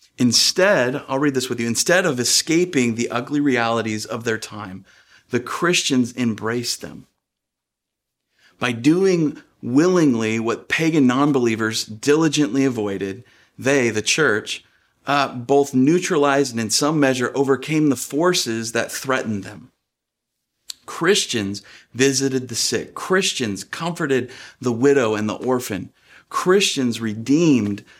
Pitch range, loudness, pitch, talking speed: 110-145 Hz, -19 LUFS, 125 Hz, 120 wpm